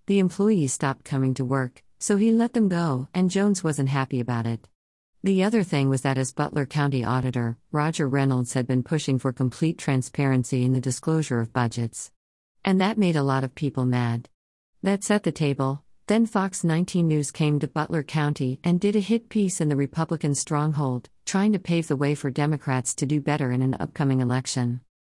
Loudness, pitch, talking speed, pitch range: -24 LUFS, 145 Hz, 195 wpm, 130-170 Hz